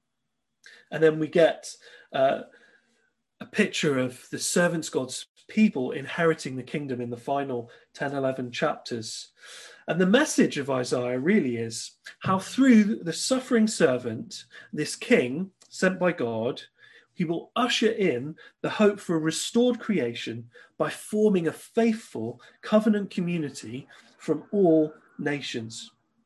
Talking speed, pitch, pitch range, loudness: 130 wpm, 160 Hz, 130-210 Hz, -26 LUFS